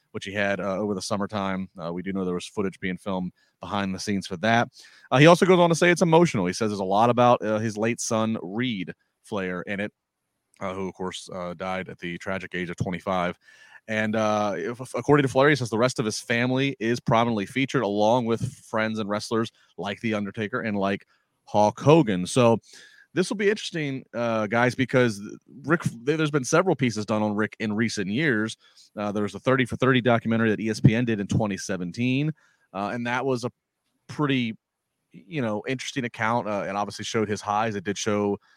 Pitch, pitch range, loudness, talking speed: 110 Hz, 100-125 Hz, -25 LUFS, 210 wpm